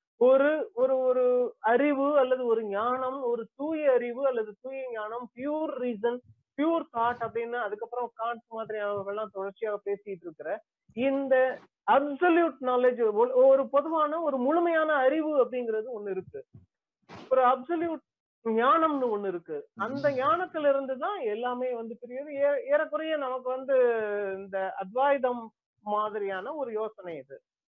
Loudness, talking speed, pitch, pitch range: -28 LUFS, 120 wpm, 255 Hz, 225-295 Hz